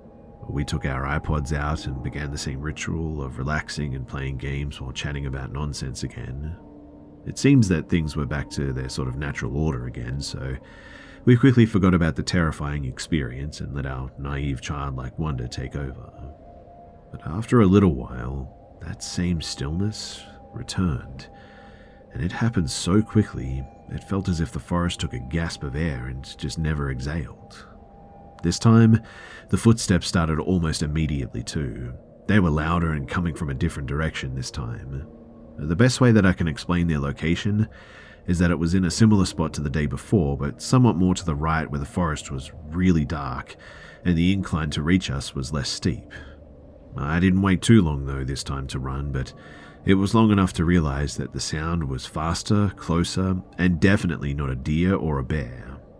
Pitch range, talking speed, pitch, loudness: 70-90 Hz, 180 wpm, 80 Hz, -24 LUFS